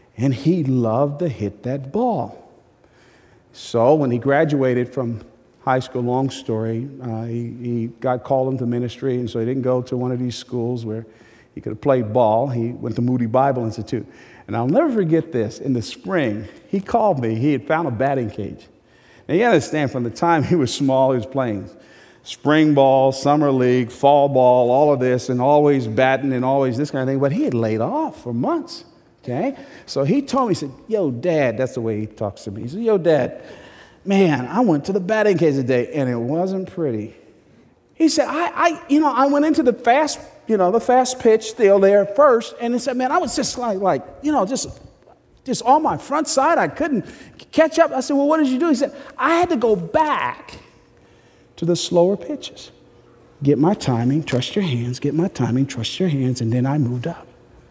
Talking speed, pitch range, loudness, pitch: 215 wpm, 125-205 Hz, -19 LUFS, 135 Hz